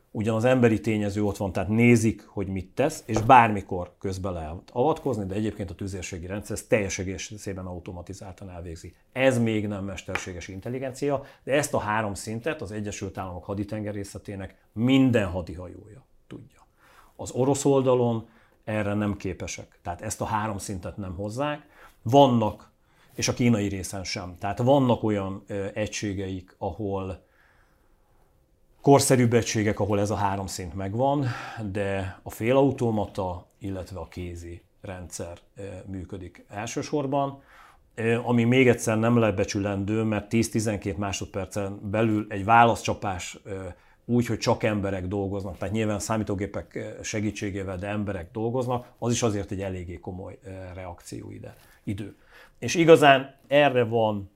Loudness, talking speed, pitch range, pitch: -25 LUFS, 130 wpm, 95-115 Hz, 105 Hz